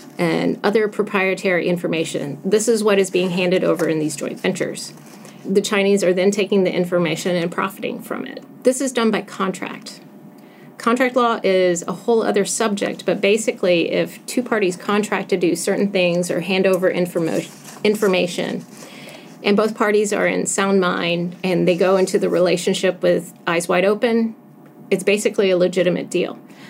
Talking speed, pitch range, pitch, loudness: 170 wpm, 180-215 Hz, 195 Hz, -19 LUFS